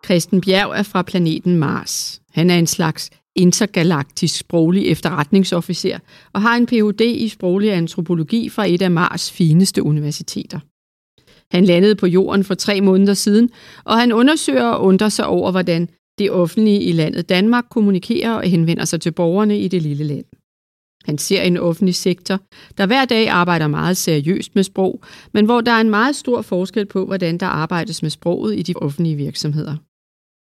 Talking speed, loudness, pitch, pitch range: 175 wpm, -16 LUFS, 185 Hz, 170-210 Hz